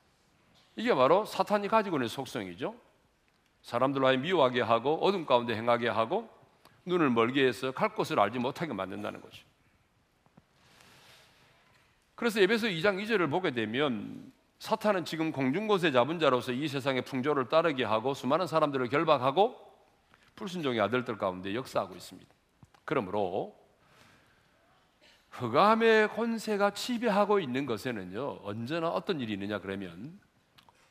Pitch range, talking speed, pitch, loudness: 125-205 Hz, 310 characters per minute, 145 Hz, -29 LUFS